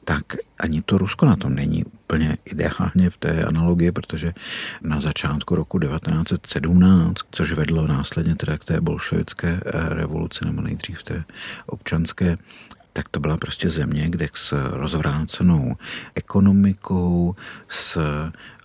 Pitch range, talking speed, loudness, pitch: 80-90 Hz, 125 wpm, -22 LUFS, 85 Hz